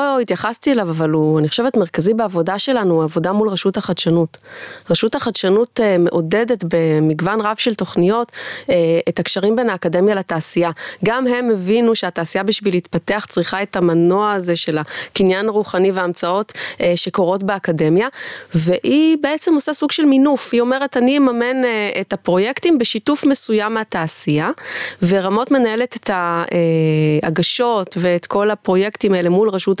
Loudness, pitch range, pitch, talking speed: -16 LUFS, 175-230 Hz, 195 Hz, 135 wpm